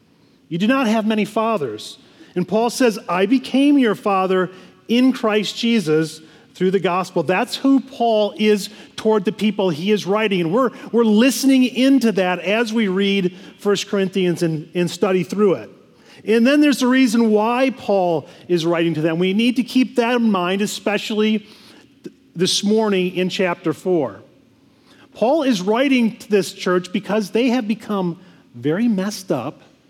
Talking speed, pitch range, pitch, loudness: 165 wpm, 185-235 Hz, 210 Hz, -18 LUFS